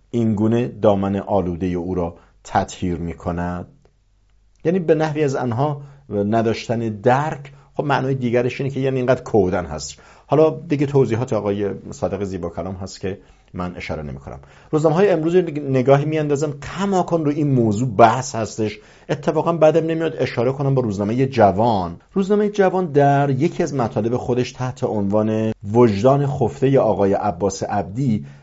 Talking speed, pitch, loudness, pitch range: 155 wpm, 120 Hz, -19 LUFS, 100-140 Hz